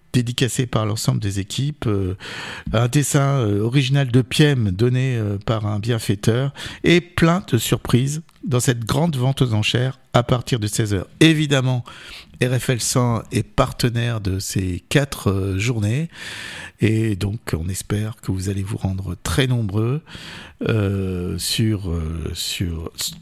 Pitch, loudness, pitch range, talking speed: 120 Hz, -20 LUFS, 105-135 Hz, 130 wpm